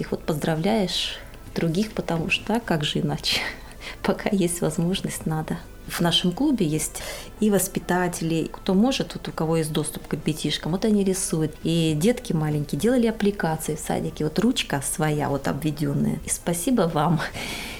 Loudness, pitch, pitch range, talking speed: -24 LUFS, 170 Hz, 155-200 Hz, 155 wpm